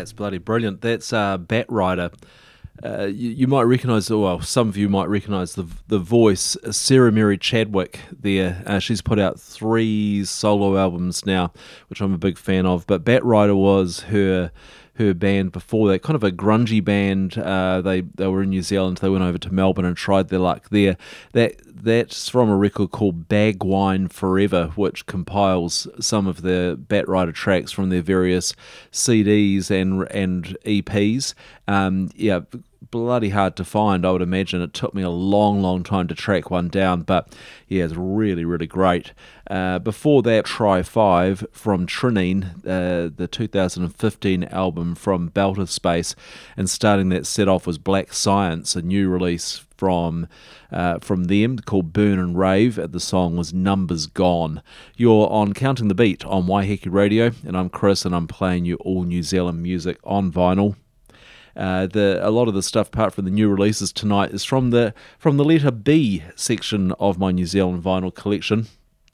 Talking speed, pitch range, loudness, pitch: 180 wpm, 90-105 Hz, -20 LUFS, 95 Hz